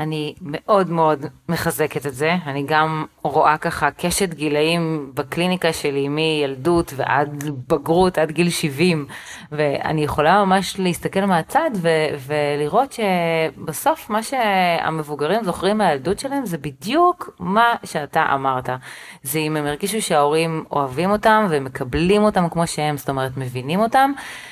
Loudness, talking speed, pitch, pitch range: -20 LUFS, 130 wpm, 160 Hz, 150-185 Hz